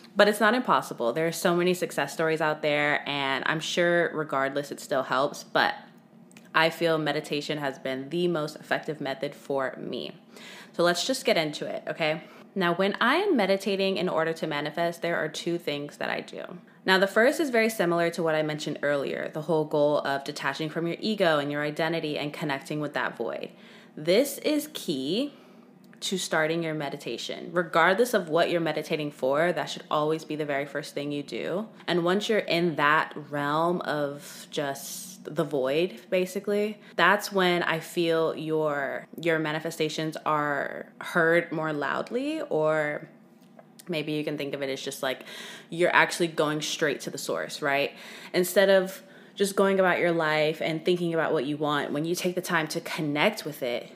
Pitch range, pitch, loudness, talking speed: 150-195 Hz, 165 Hz, -27 LUFS, 185 wpm